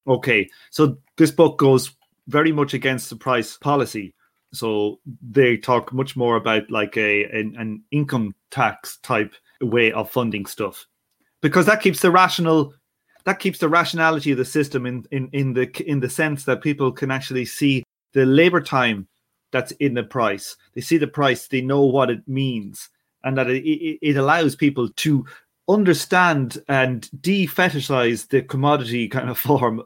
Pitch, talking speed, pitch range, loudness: 135 Hz, 165 wpm, 125-150 Hz, -20 LUFS